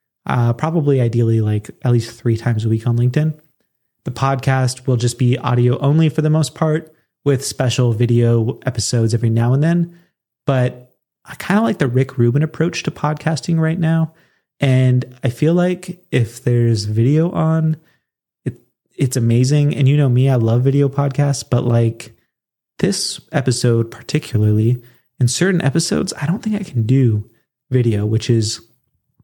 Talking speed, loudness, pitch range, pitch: 165 wpm, -17 LUFS, 120-155 Hz, 130 Hz